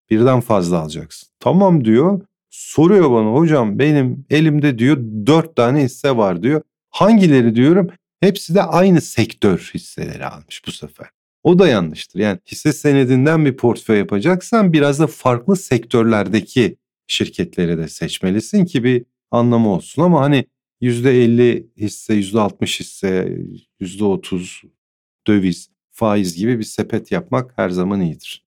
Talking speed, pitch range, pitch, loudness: 135 wpm, 110-155 Hz, 125 Hz, -16 LUFS